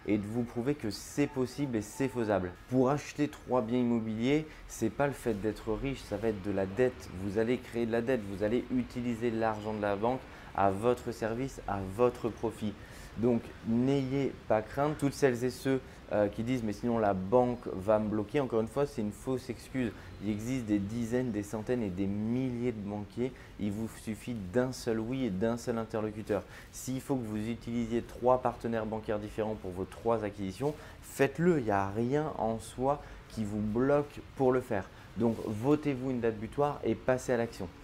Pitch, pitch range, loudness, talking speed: 115 Hz, 105-125 Hz, -33 LUFS, 205 wpm